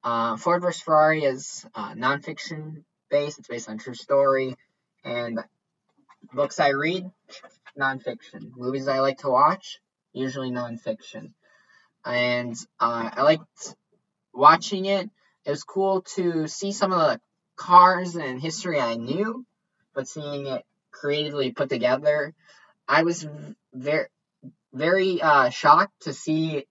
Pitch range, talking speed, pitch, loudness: 130-180 Hz, 135 wpm, 150 Hz, -23 LUFS